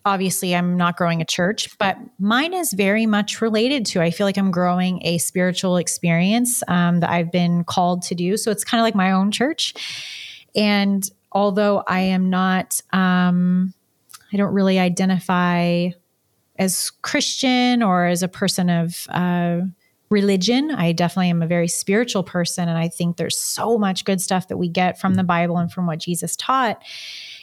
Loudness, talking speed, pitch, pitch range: -20 LUFS, 175 wpm, 185 Hz, 175-205 Hz